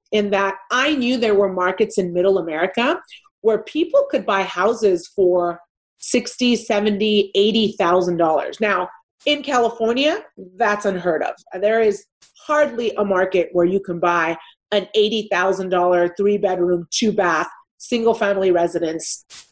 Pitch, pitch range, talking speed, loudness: 205 Hz, 180-235 Hz, 145 wpm, -19 LUFS